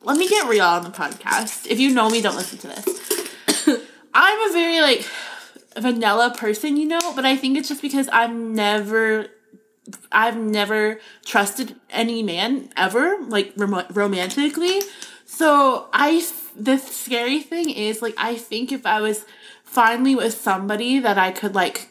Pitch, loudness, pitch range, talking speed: 235 Hz, -20 LUFS, 215-300 Hz, 160 wpm